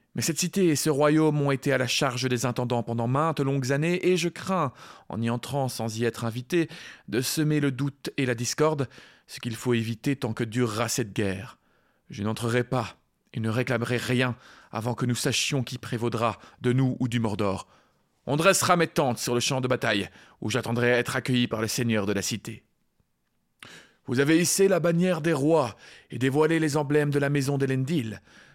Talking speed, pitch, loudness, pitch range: 200 wpm, 130 Hz, -26 LUFS, 120-150 Hz